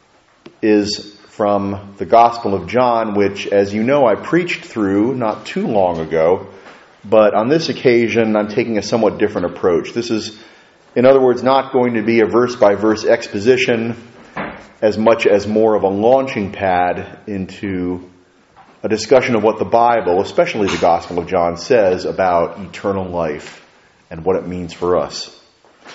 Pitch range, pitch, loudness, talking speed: 100-115 Hz, 110 Hz, -16 LUFS, 165 wpm